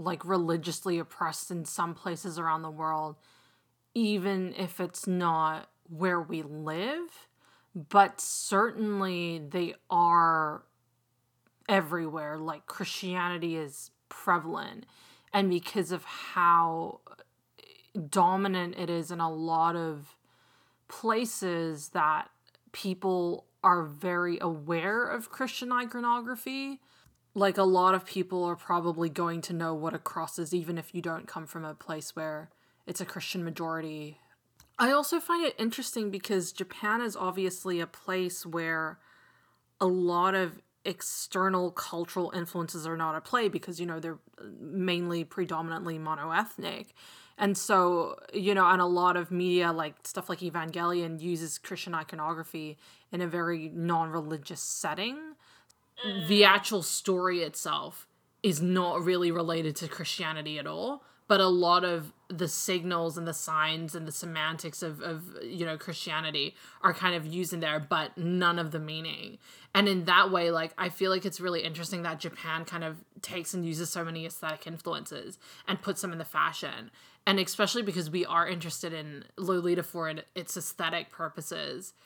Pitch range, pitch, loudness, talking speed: 165-190 Hz, 175 Hz, -30 LUFS, 150 wpm